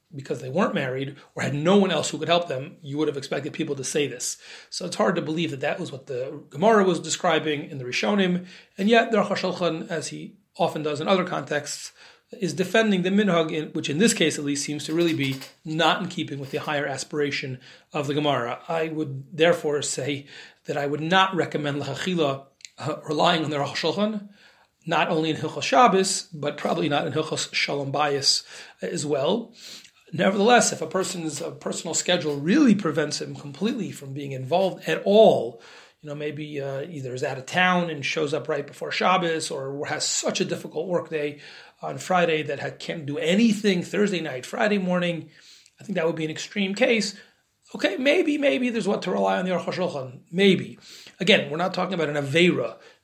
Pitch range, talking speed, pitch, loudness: 145-185 Hz, 205 wpm, 160 Hz, -24 LUFS